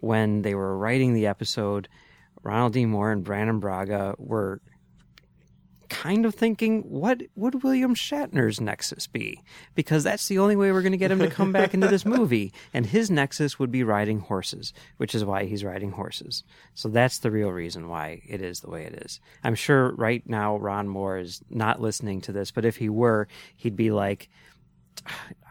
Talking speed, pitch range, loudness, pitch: 195 wpm, 100-160 Hz, -25 LUFS, 115 Hz